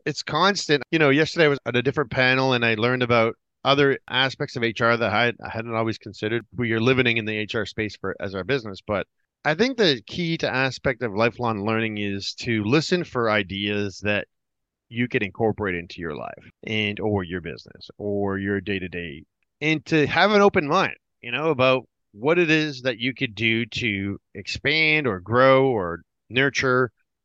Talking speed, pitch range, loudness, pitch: 185 wpm, 105-140 Hz, -22 LUFS, 120 Hz